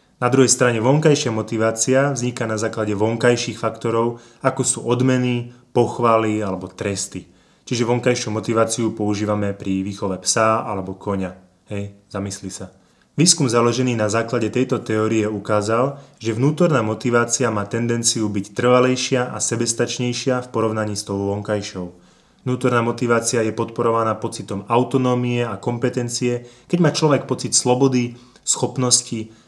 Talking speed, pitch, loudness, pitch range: 130 wpm, 115 Hz, -19 LUFS, 110-125 Hz